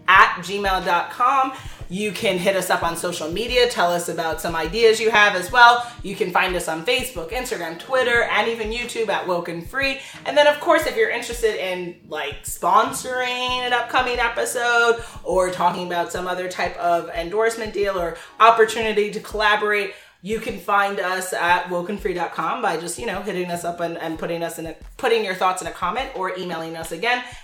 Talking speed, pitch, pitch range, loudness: 190 wpm, 200 Hz, 175-235 Hz, -21 LUFS